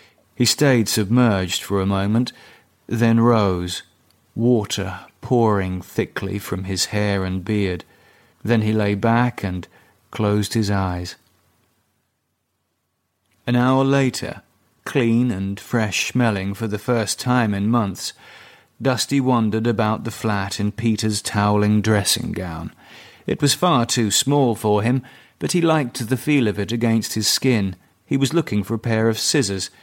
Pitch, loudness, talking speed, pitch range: 110 Hz, -20 LUFS, 145 wpm, 100-120 Hz